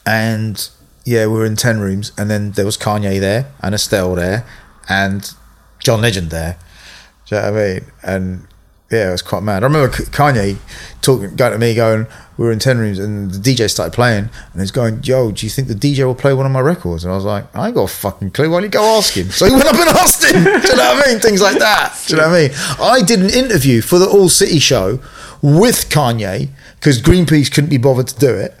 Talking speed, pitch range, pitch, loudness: 255 wpm, 100-140 Hz, 115 Hz, -13 LUFS